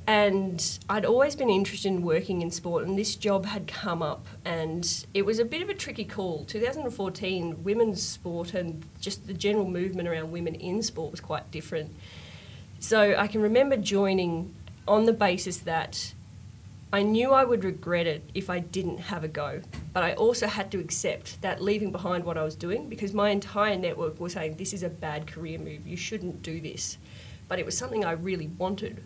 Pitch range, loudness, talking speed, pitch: 165-205 Hz, -28 LUFS, 200 wpm, 180 Hz